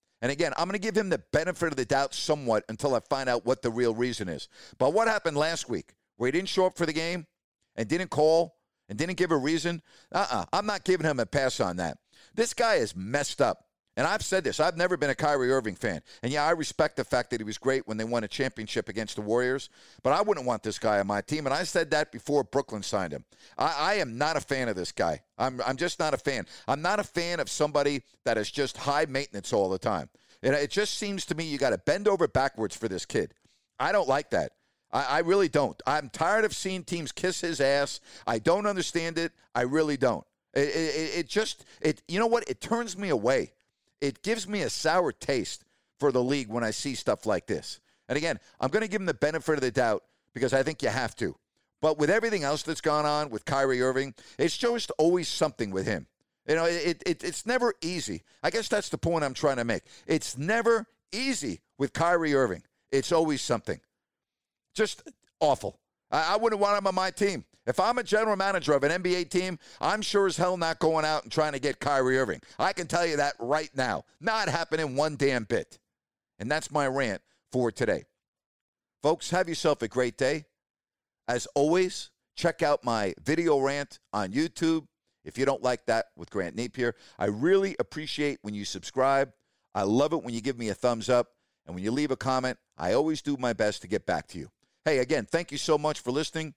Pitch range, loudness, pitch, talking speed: 125-175 Hz, -28 LUFS, 150 Hz, 230 wpm